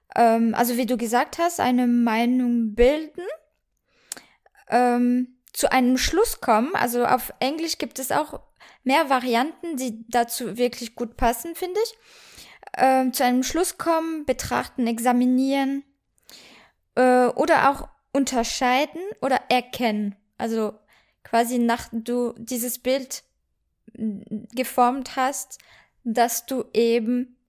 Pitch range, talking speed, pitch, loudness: 235-275 Hz, 115 wpm, 250 Hz, -23 LUFS